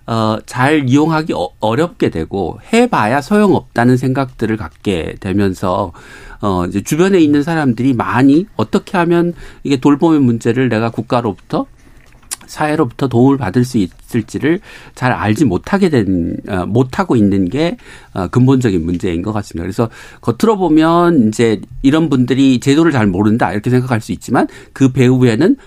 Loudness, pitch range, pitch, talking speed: -14 LUFS, 110-150 Hz, 125 Hz, 330 characters per minute